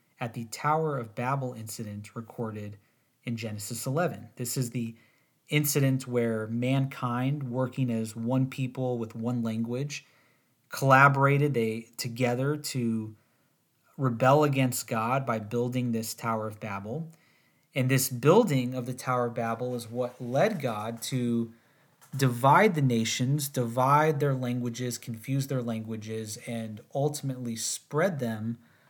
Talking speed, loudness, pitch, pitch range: 130 wpm, -28 LUFS, 125 Hz, 115-135 Hz